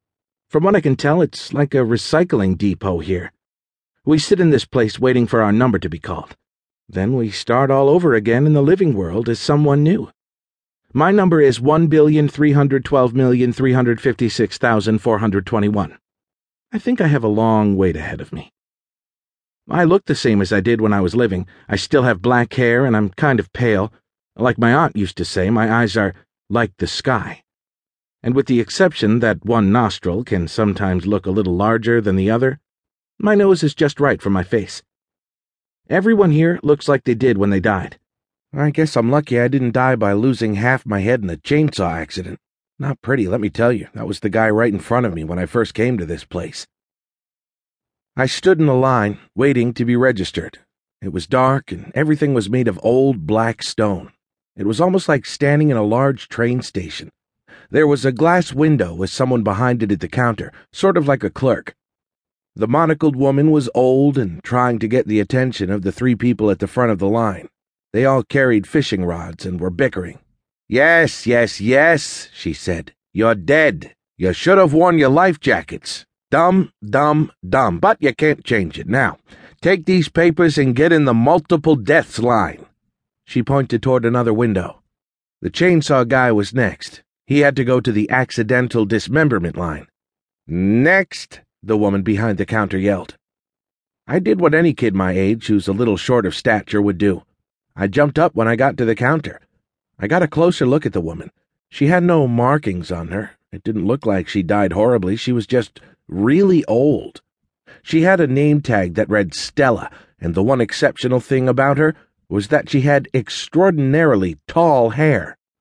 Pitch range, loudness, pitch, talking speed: 105-145 Hz, -16 LUFS, 120 Hz, 185 wpm